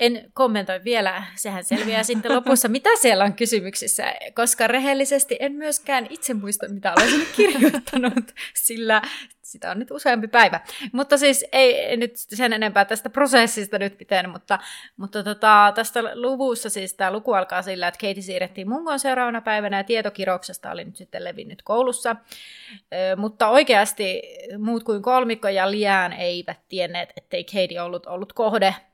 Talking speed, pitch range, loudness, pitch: 150 wpm, 195-260 Hz, -21 LUFS, 225 Hz